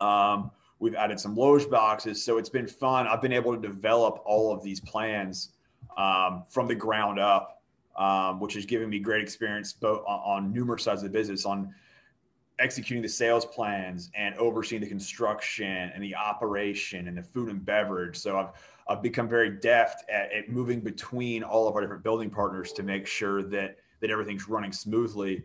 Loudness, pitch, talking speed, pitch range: -28 LUFS, 105 Hz, 185 wpm, 100-115 Hz